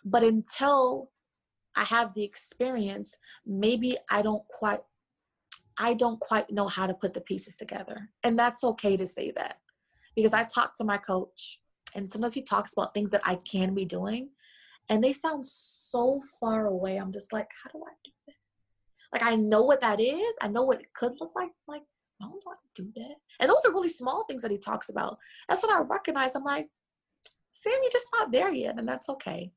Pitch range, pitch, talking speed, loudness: 205-280 Hz, 235 Hz, 215 wpm, -29 LUFS